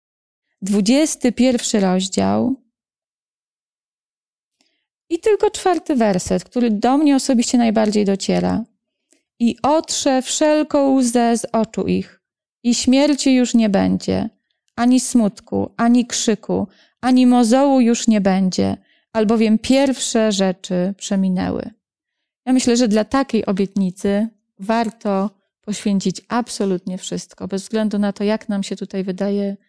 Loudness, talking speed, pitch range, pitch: -18 LUFS, 115 wpm, 195-255 Hz, 225 Hz